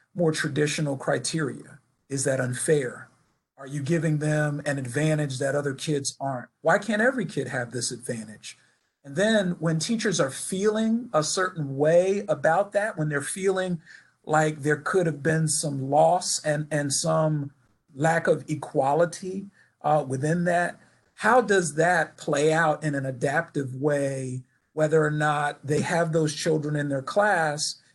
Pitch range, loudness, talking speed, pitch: 140-170 Hz, -25 LUFS, 155 wpm, 150 Hz